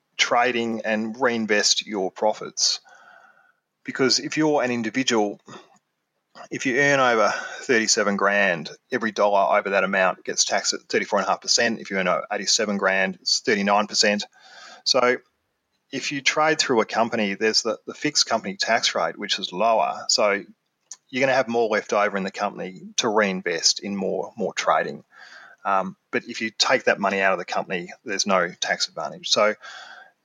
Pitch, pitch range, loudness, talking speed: 110 Hz, 100-120 Hz, -22 LUFS, 165 wpm